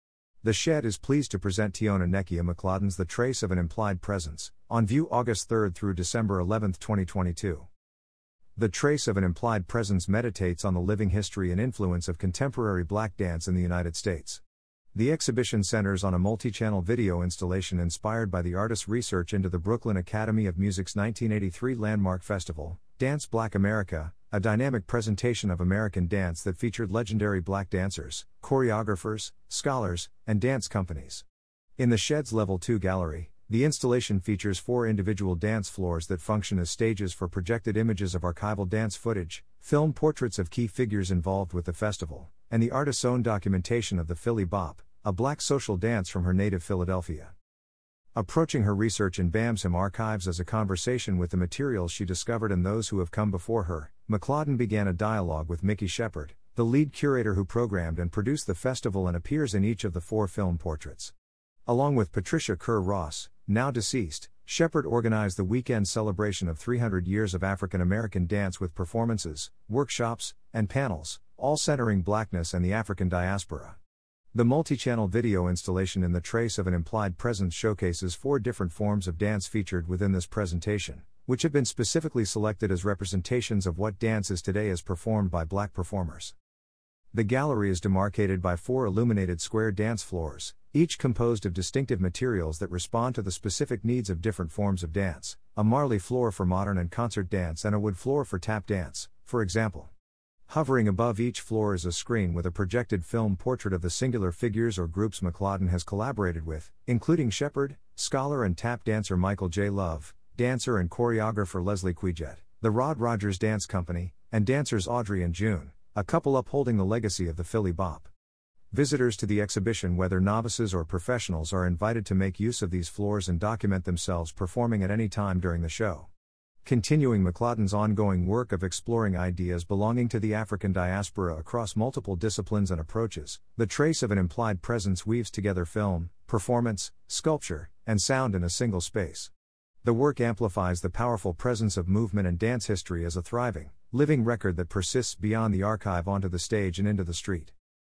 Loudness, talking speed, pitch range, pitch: -29 LUFS, 180 wpm, 90-115 Hz, 100 Hz